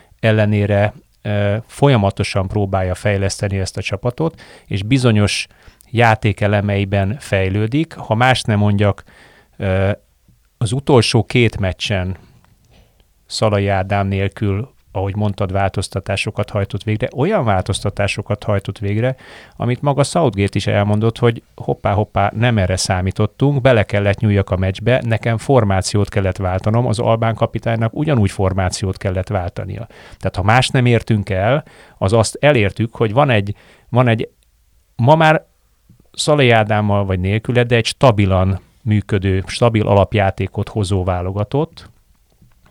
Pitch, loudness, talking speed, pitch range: 105 Hz, -17 LUFS, 120 wpm, 100-115 Hz